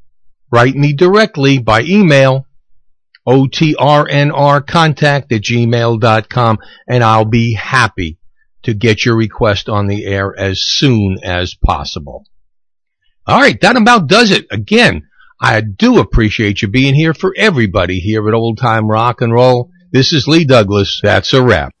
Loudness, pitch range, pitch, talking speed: -11 LUFS, 105-140 Hz, 120 Hz, 145 wpm